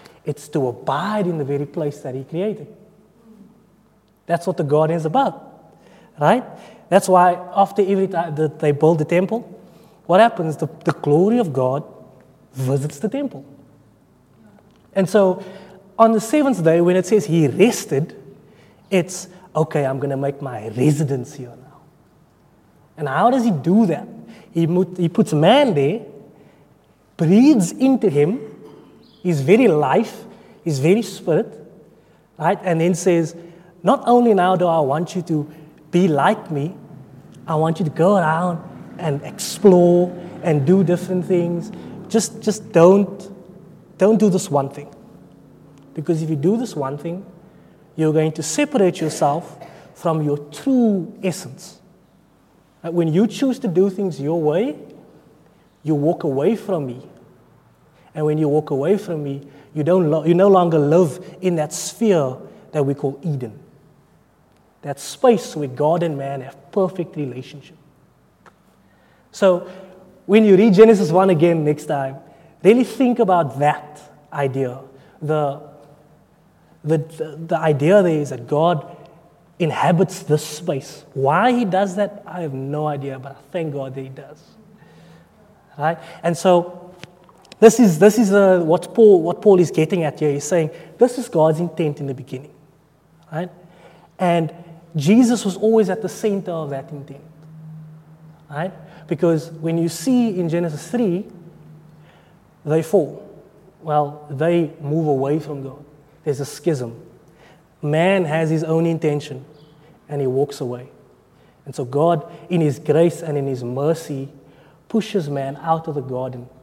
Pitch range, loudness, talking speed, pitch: 150-190 Hz, -18 LUFS, 150 wpm, 165 Hz